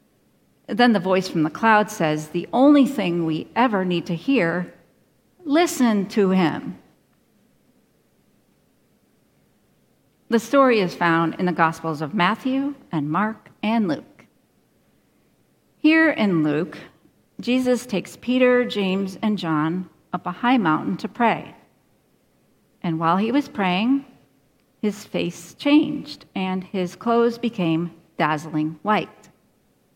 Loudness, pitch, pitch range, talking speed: -21 LUFS, 195 Hz, 170-245 Hz, 120 wpm